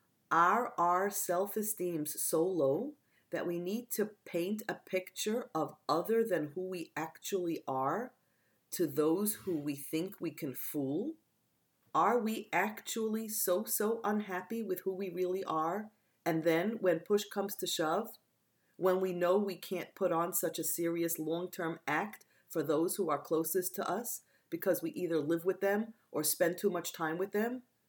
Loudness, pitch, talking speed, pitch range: -34 LUFS, 180 Hz, 170 wpm, 165-205 Hz